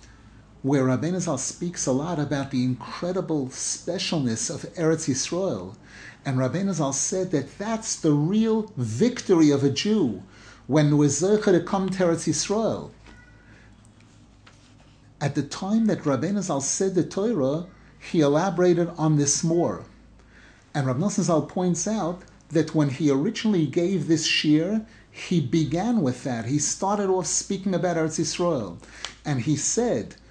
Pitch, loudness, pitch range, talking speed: 160 Hz, -24 LUFS, 135-180 Hz, 140 wpm